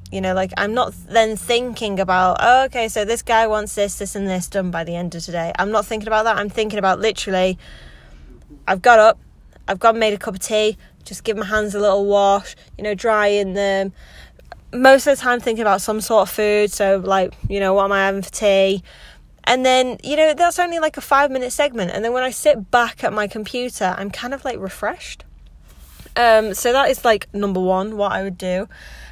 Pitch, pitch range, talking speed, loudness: 210 Hz, 190-235 Hz, 225 wpm, -18 LUFS